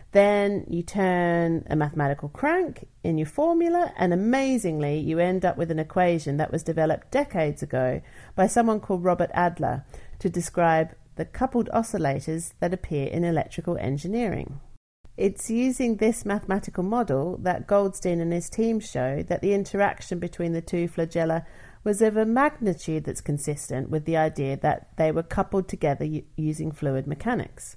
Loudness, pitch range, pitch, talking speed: -25 LUFS, 155-200 Hz, 175 Hz, 155 wpm